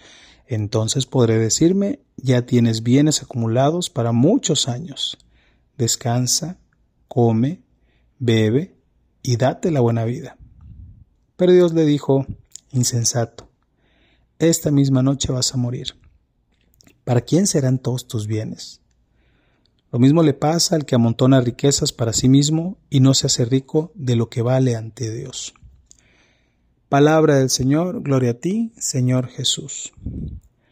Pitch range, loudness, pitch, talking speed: 115-145 Hz, -18 LUFS, 130 Hz, 125 wpm